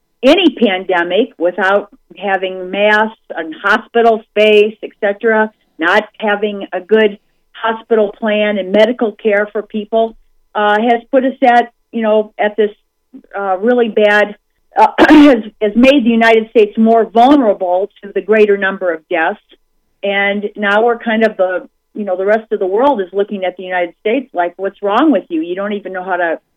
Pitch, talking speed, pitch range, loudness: 210 Hz, 175 wpm, 195-230 Hz, -13 LUFS